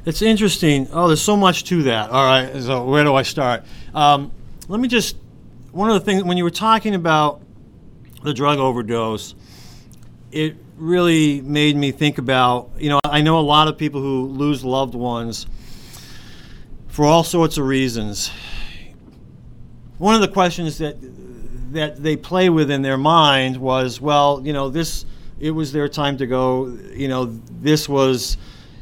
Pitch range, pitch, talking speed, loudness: 130-160 Hz, 145 Hz, 170 wpm, -18 LUFS